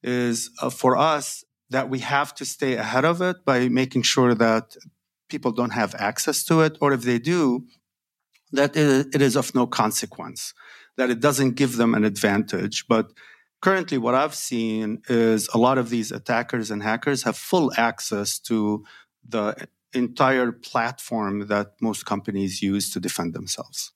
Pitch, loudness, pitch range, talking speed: 125 Hz, -23 LUFS, 110-135 Hz, 165 wpm